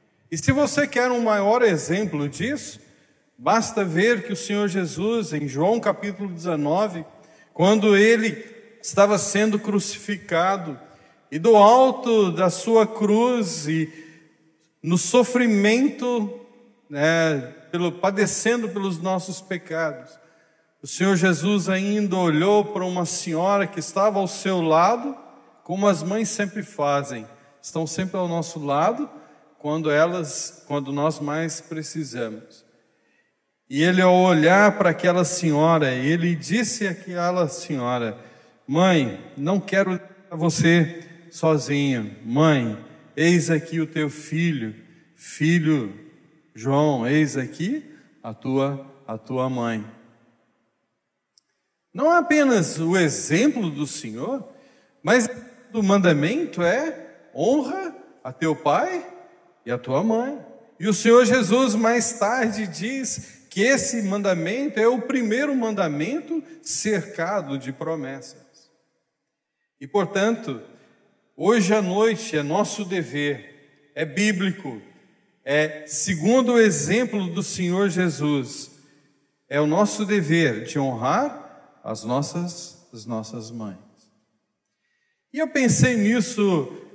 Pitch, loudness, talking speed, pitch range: 180 Hz, -21 LUFS, 115 wpm, 155-215 Hz